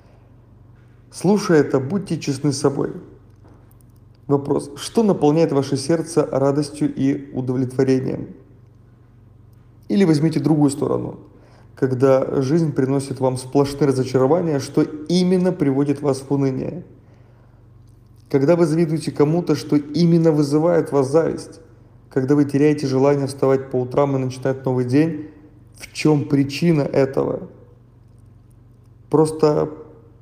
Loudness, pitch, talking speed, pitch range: -19 LUFS, 135 Hz, 110 wpm, 120-150 Hz